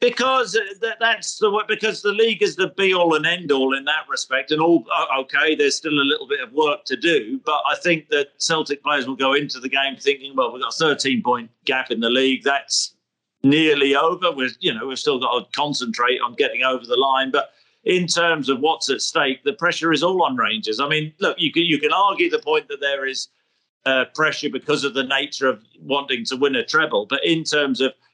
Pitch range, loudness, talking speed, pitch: 135-205 Hz, -20 LUFS, 230 wpm, 150 Hz